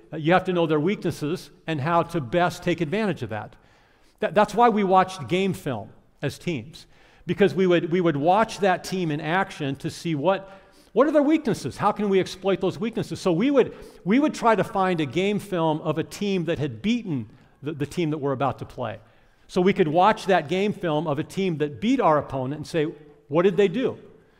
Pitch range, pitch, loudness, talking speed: 150-195 Hz, 175 Hz, -24 LUFS, 225 wpm